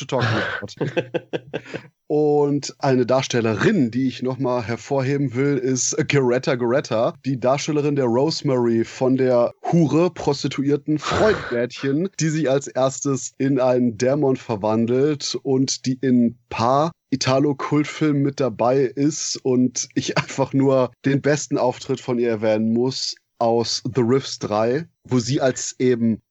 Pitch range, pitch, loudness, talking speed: 125-145 Hz, 130 Hz, -21 LUFS, 130 wpm